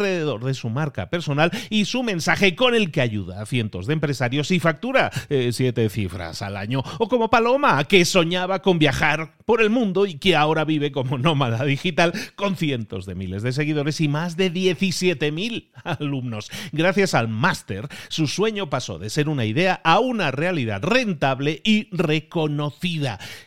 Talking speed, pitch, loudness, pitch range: 170 wpm, 155 Hz, -21 LUFS, 135-185 Hz